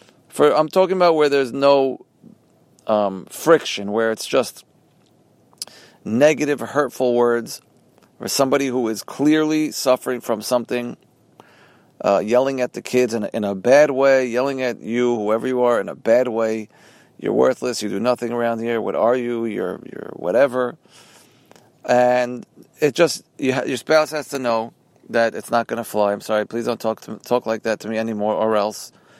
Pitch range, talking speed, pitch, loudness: 110-135 Hz, 180 wpm, 120 Hz, -20 LUFS